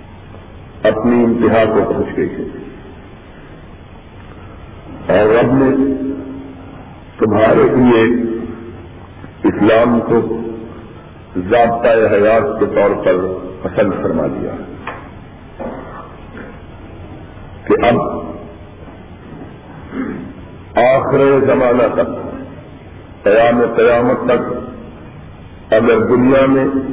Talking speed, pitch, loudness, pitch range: 70 wpm, 110 Hz, -13 LUFS, 95-120 Hz